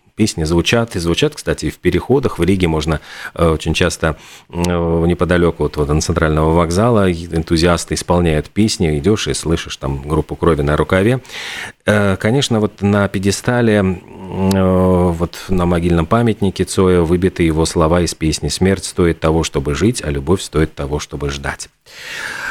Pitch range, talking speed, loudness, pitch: 80-95 Hz, 145 wpm, -16 LUFS, 85 Hz